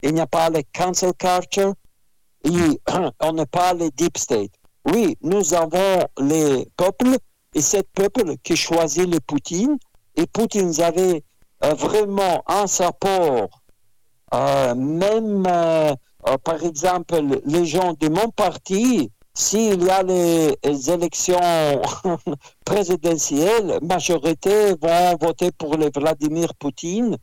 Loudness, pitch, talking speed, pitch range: -20 LUFS, 170 Hz, 130 wpm, 155-190 Hz